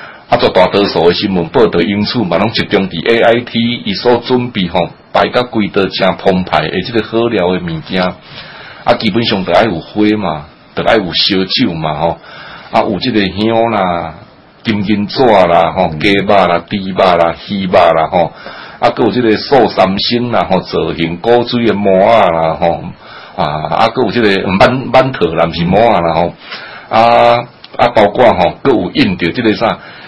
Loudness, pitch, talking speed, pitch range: -11 LUFS, 100 Hz, 255 characters per minute, 85-115 Hz